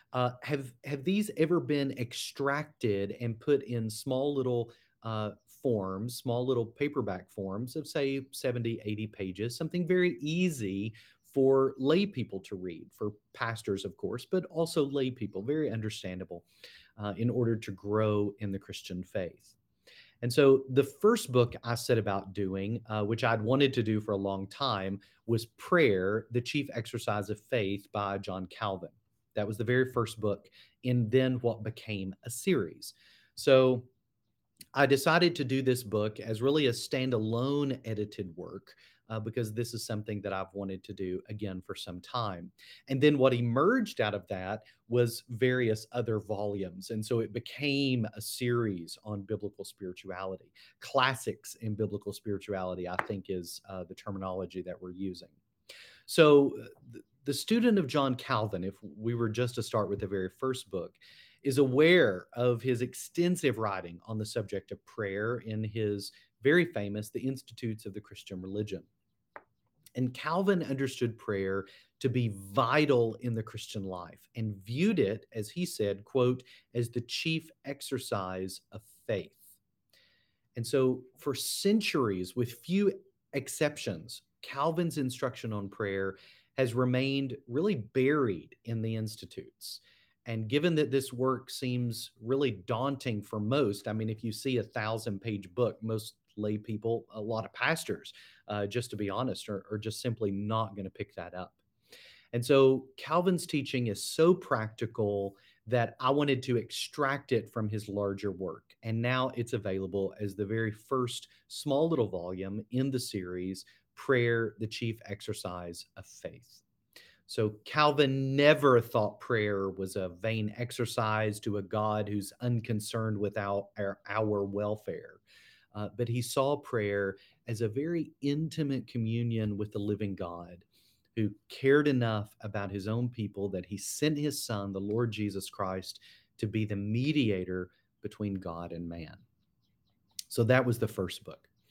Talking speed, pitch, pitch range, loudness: 155 wpm, 115 Hz, 100-130 Hz, -32 LUFS